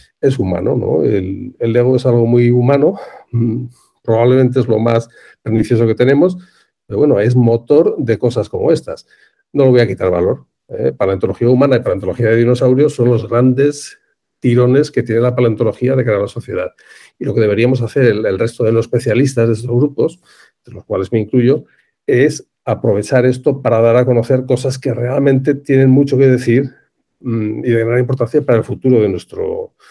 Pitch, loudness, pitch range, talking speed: 125 Hz, -14 LUFS, 115-130 Hz, 190 wpm